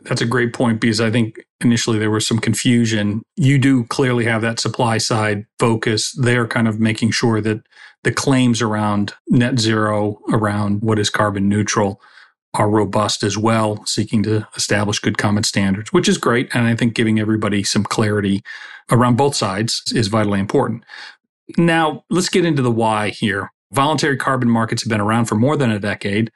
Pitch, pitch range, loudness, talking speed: 115 Hz, 105-120 Hz, -17 LUFS, 180 wpm